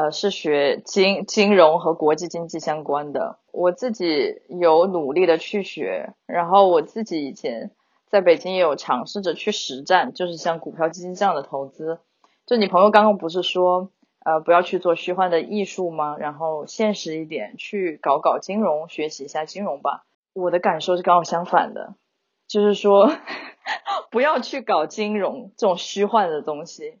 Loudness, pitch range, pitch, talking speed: -21 LUFS, 160-205 Hz, 180 Hz, 260 characters per minute